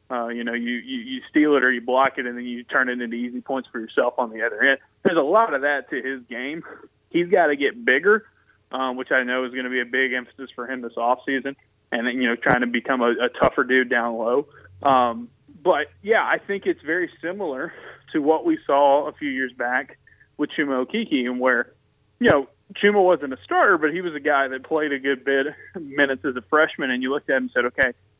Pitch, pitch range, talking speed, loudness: 130 Hz, 120-140 Hz, 250 wpm, -22 LUFS